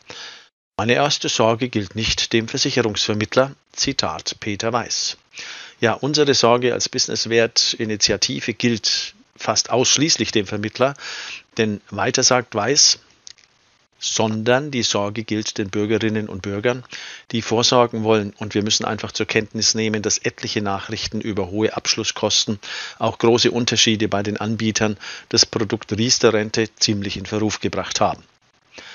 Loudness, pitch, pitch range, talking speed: -19 LUFS, 110 Hz, 105-120 Hz, 135 wpm